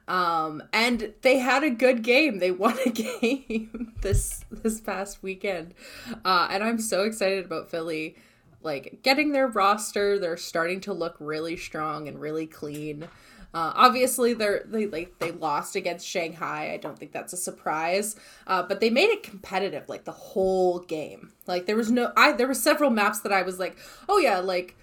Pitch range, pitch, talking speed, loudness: 170-235 Hz, 195 Hz, 185 wpm, -25 LUFS